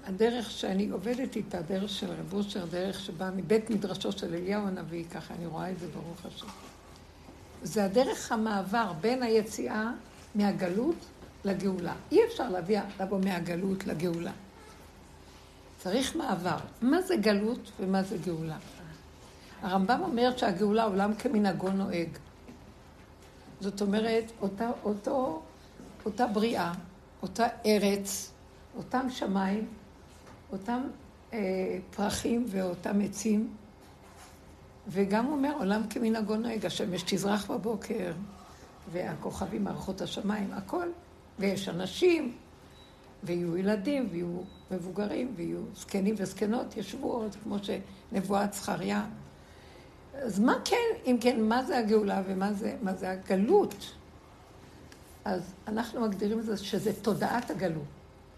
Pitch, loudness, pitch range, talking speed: 205 Hz, -31 LUFS, 185-230 Hz, 110 wpm